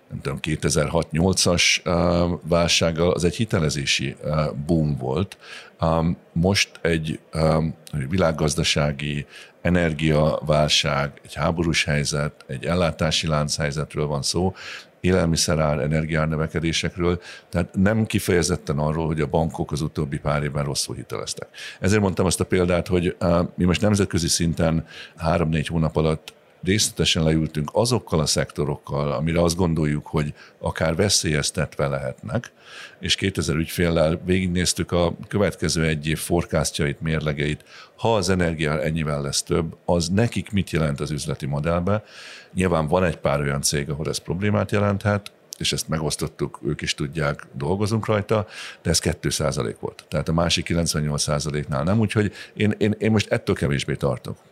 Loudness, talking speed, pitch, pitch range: -22 LUFS, 130 wpm, 80 Hz, 75-90 Hz